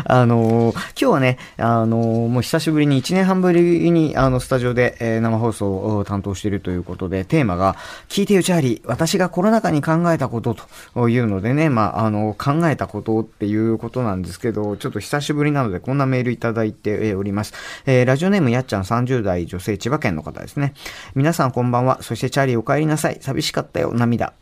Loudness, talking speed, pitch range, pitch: -19 LUFS, 440 characters per minute, 110-145 Hz, 120 Hz